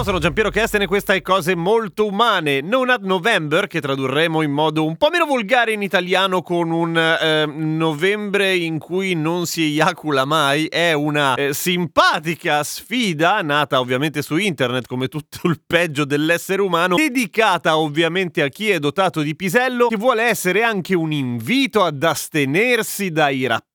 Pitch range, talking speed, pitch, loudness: 155-200 Hz, 165 wpm, 170 Hz, -18 LUFS